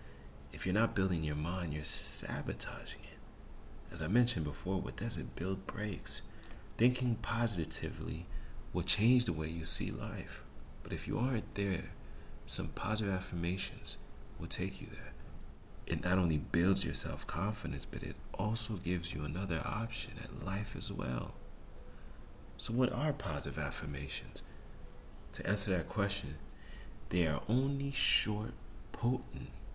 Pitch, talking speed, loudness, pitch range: 95 Hz, 140 wpm, -36 LUFS, 75-105 Hz